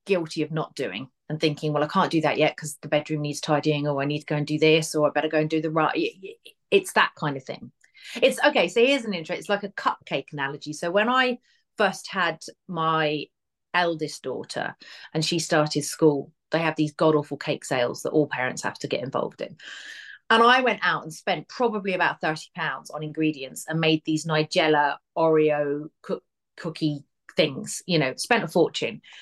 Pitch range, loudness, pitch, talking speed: 150-175 Hz, -24 LUFS, 155 Hz, 205 wpm